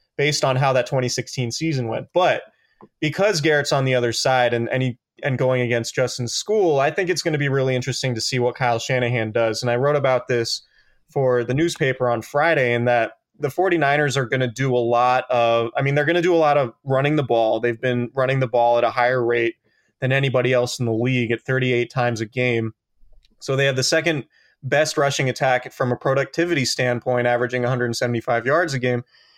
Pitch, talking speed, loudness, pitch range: 125 Hz, 215 wpm, -20 LUFS, 120-140 Hz